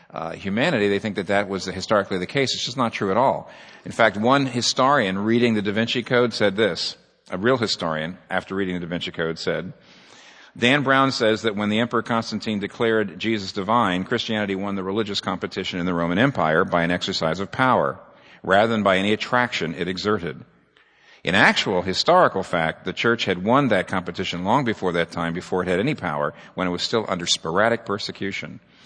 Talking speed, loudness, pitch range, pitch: 200 wpm, -22 LUFS, 90-115 Hz, 100 Hz